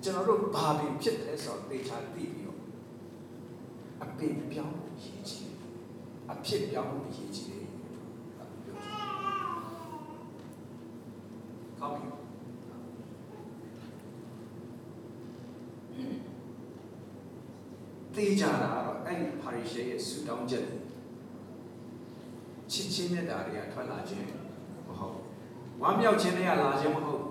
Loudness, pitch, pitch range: -34 LUFS, 120 Hz, 115-155 Hz